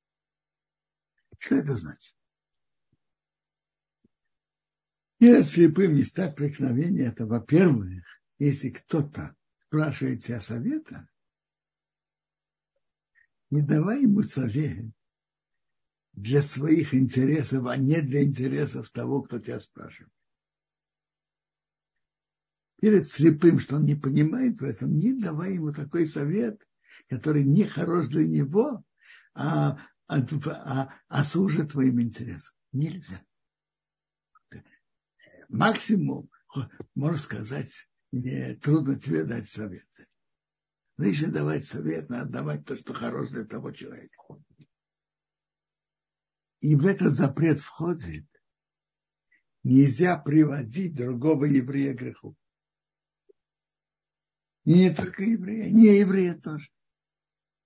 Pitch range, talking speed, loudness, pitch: 130-175 Hz, 95 wpm, -25 LUFS, 145 Hz